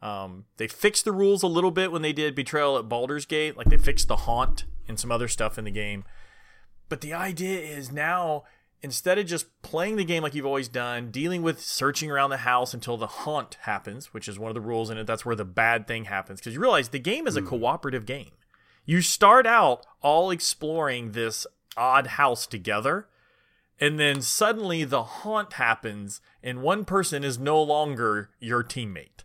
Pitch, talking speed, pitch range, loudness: 140 Hz, 200 wpm, 115-165 Hz, -25 LUFS